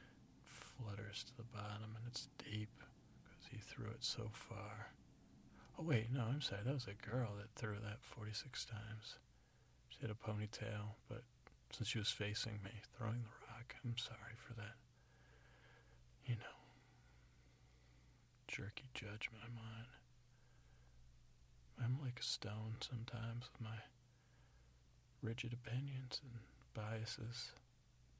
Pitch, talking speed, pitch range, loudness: 115 Hz, 130 wpm, 105-120 Hz, -48 LUFS